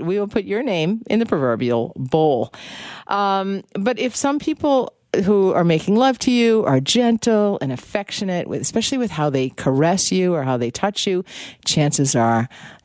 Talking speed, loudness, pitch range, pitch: 175 wpm, -19 LUFS, 150-225 Hz, 195 Hz